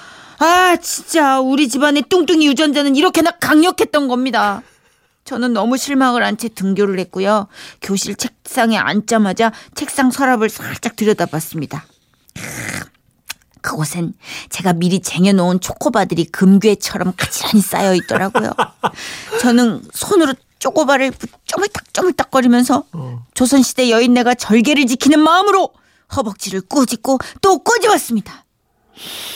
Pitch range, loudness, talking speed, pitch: 195-295 Hz, -15 LUFS, 300 characters per minute, 245 Hz